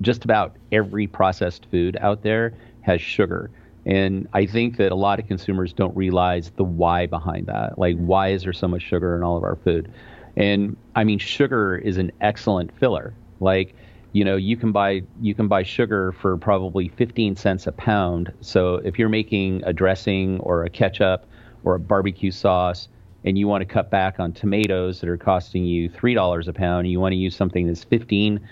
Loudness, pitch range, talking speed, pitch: -22 LUFS, 90-105 Hz, 200 wpm, 95 Hz